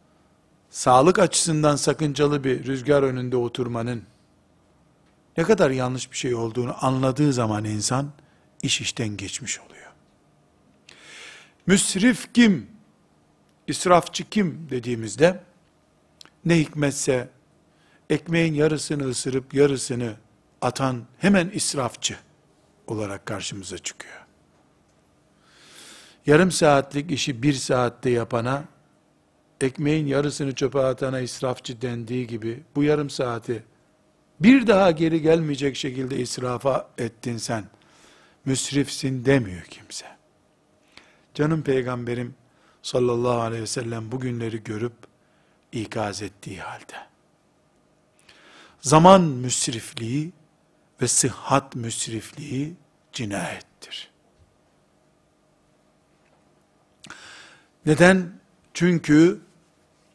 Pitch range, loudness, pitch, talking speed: 120-155 Hz, -23 LUFS, 135 Hz, 85 wpm